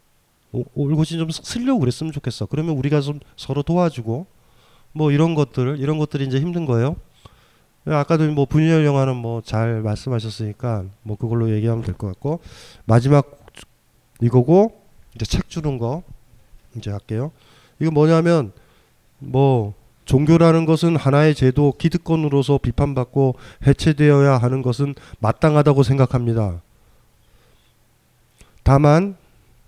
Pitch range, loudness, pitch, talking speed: 115-150 Hz, -19 LUFS, 135 Hz, 280 characters per minute